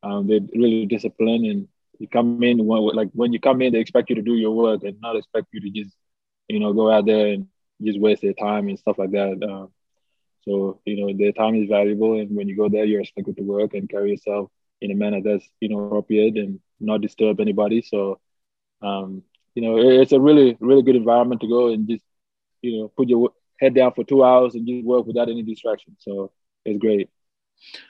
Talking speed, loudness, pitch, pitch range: 225 wpm, -20 LUFS, 110 Hz, 100-120 Hz